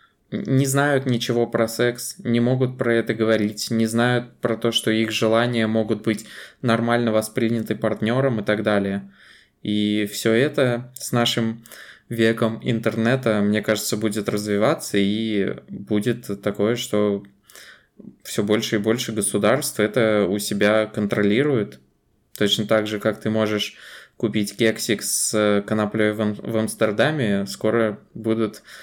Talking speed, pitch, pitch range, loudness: 130 wpm, 110 Hz, 105-115 Hz, -21 LUFS